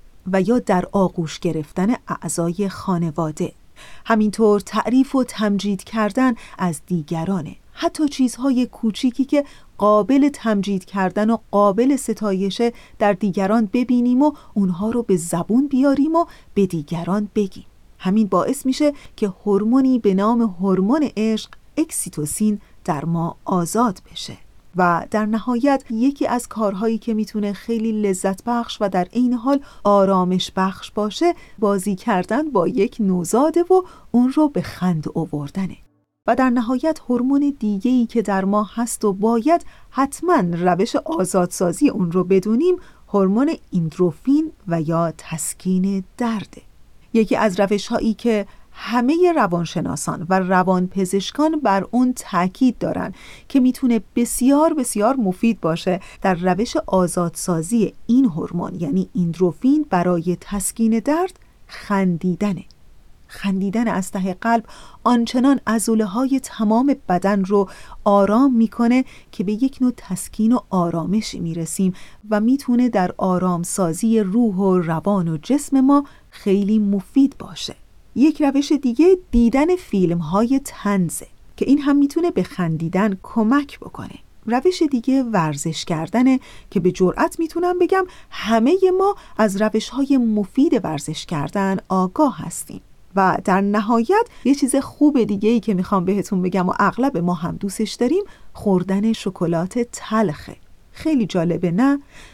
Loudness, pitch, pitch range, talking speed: -19 LUFS, 215 Hz, 185-255 Hz, 130 wpm